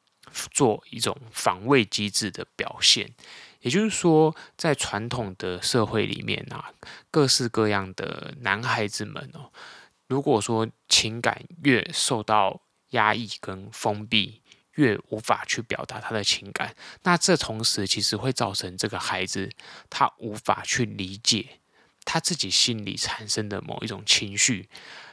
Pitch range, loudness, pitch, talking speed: 105-130 Hz, -24 LUFS, 110 Hz, 210 characters per minute